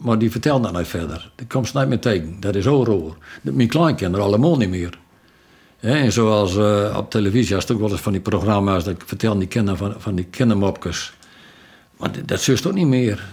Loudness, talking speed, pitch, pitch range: -19 LUFS, 225 wpm, 105 Hz, 95-125 Hz